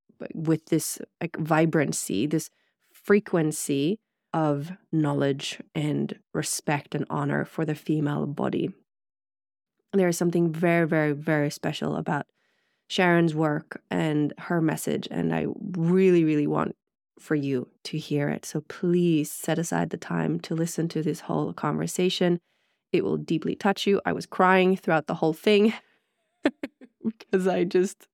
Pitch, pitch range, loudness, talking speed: 165 Hz, 155-185 Hz, -26 LUFS, 140 wpm